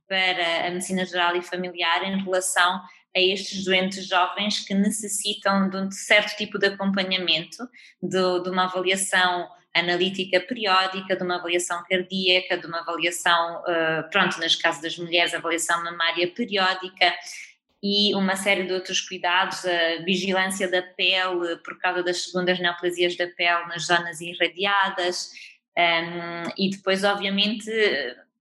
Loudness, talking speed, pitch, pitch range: -23 LUFS, 135 wpm, 185 Hz, 175-190 Hz